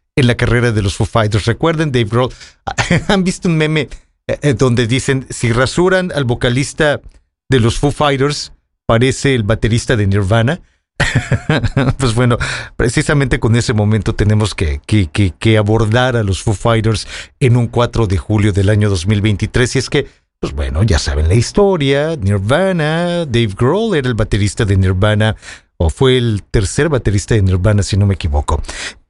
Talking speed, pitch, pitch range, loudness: 165 wpm, 115 Hz, 105-135 Hz, -14 LUFS